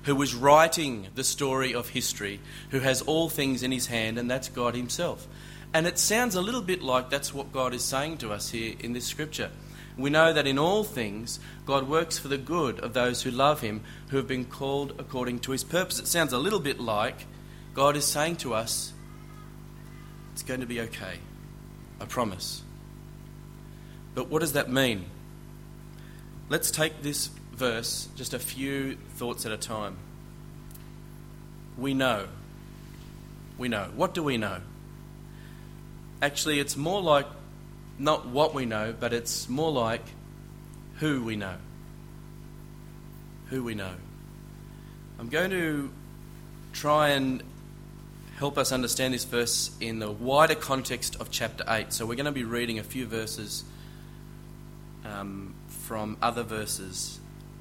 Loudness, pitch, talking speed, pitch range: -28 LUFS, 135 Hz, 155 wpm, 120-150 Hz